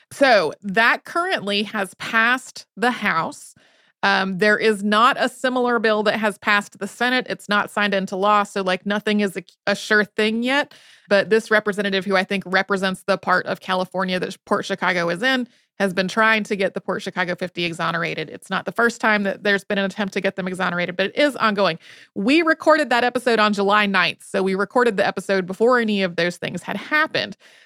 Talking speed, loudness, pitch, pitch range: 210 wpm, -20 LUFS, 205 Hz, 190-220 Hz